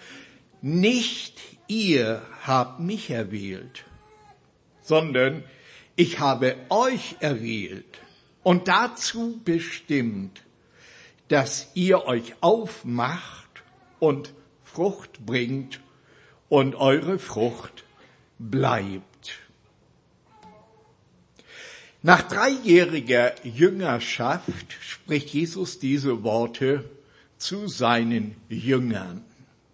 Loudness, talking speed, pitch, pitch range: -24 LUFS, 70 wpm, 140 Hz, 120-180 Hz